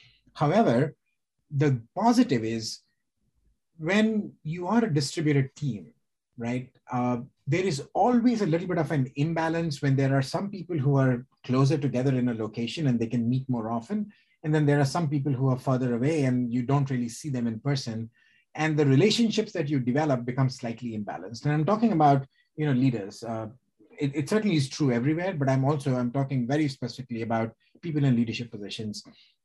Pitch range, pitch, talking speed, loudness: 125-155 Hz, 135 Hz, 185 wpm, -27 LUFS